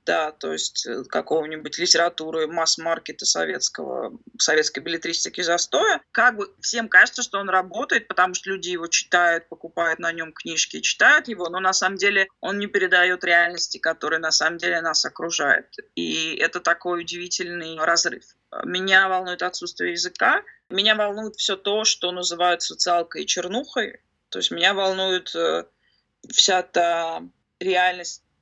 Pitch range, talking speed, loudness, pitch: 165-190 Hz, 140 wpm, -21 LUFS, 180 Hz